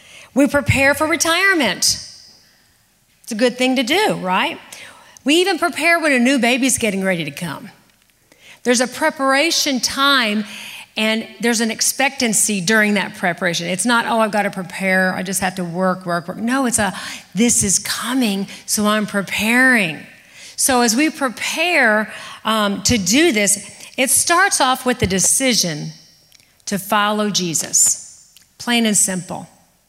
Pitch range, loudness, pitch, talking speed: 200-265 Hz, -16 LUFS, 230 Hz, 155 wpm